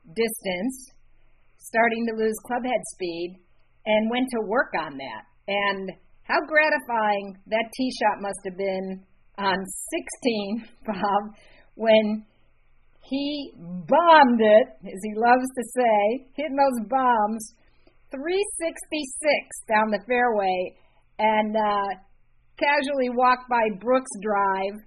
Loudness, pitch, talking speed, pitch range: -24 LUFS, 225 Hz, 115 wpm, 200-260 Hz